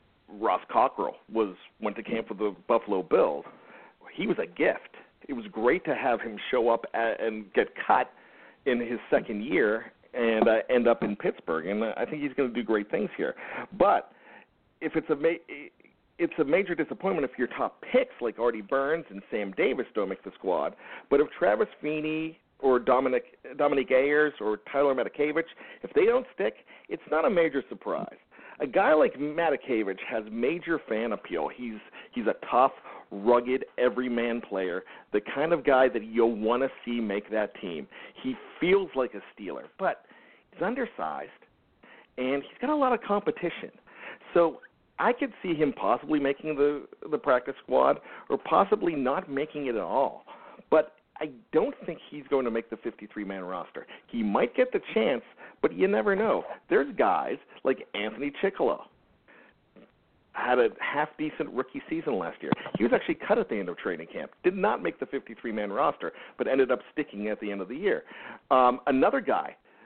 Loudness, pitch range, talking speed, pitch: -28 LUFS, 115-160 Hz, 180 wpm, 135 Hz